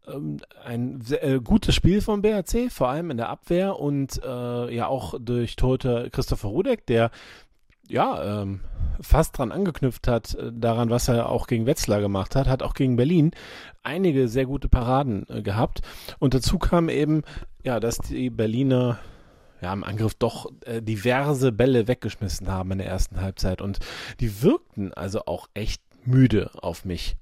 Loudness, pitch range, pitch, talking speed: -25 LUFS, 105-135 Hz, 120 Hz, 165 wpm